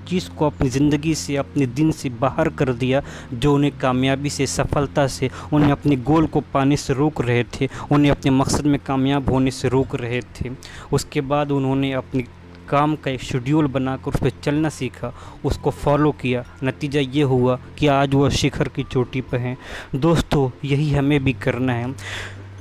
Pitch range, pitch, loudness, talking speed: 130-145 Hz, 135 Hz, -20 LUFS, 185 wpm